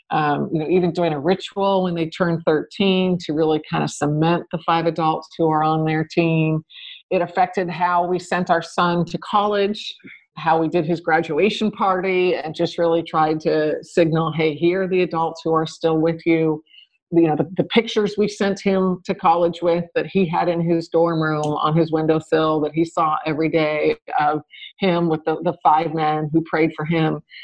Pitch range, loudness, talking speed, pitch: 160-180 Hz, -20 LUFS, 200 wpm, 165 Hz